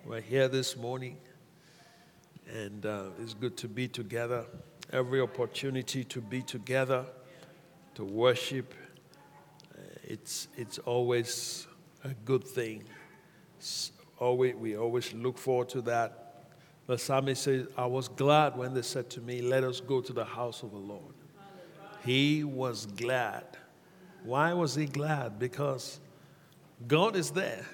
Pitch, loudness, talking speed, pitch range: 130 Hz, -32 LUFS, 135 wpm, 125-150 Hz